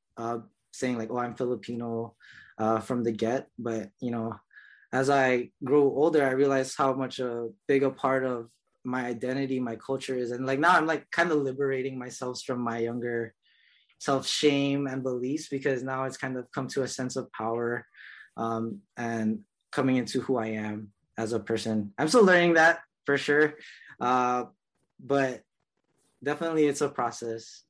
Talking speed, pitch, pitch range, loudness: 170 wpm, 130 Hz, 115-135 Hz, -28 LUFS